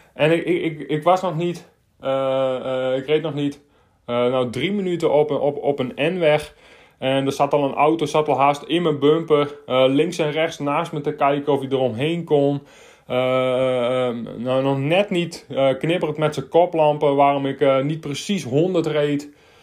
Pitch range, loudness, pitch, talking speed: 135-155 Hz, -20 LUFS, 145 Hz, 200 wpm